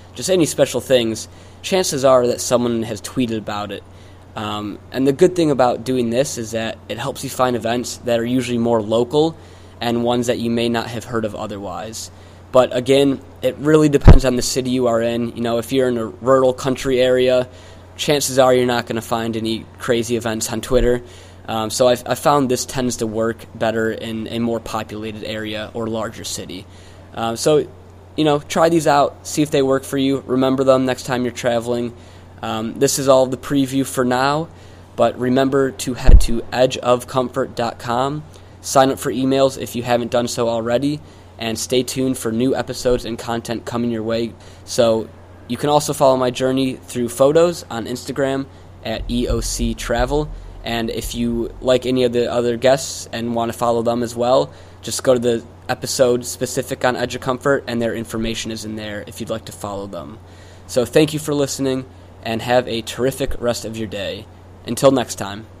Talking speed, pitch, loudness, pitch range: 195 wpm, 120 Hz, -19 LUFS, 110-130 Hz